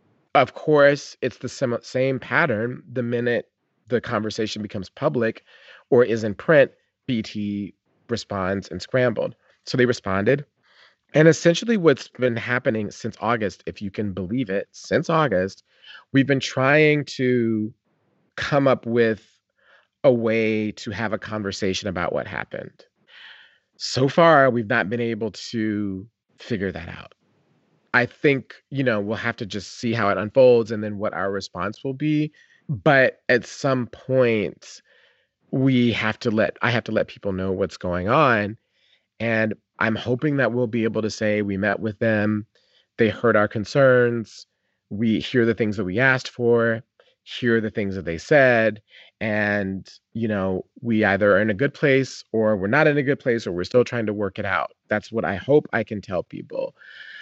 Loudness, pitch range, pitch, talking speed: -22 LUFS, 105-130 Hz, 115 Hz, 170 wpm